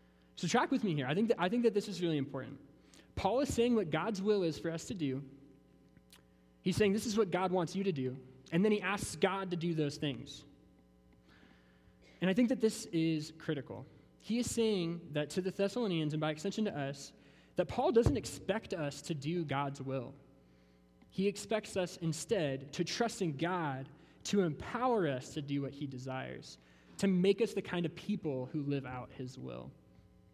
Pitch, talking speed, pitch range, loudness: 160 Hz, 200 wpm, 135-195 Hz, -35 LUFS